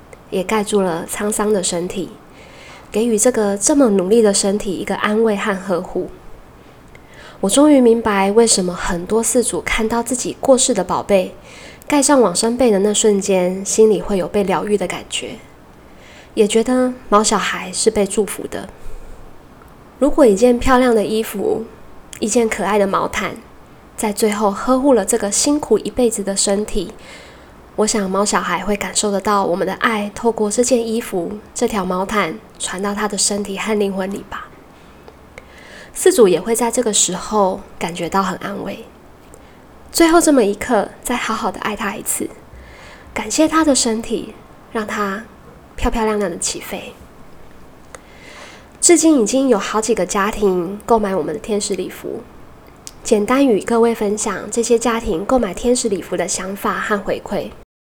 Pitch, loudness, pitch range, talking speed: 210 Hz, -17 LUFS, 195-235 Hz, 240 characters per minute